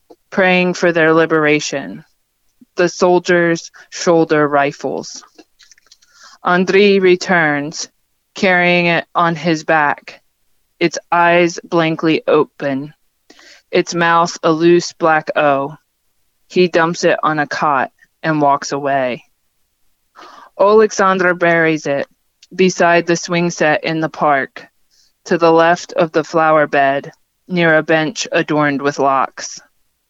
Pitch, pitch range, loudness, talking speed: 165 Hz, 155-180 Hz, -14 LUFS, 115 wpm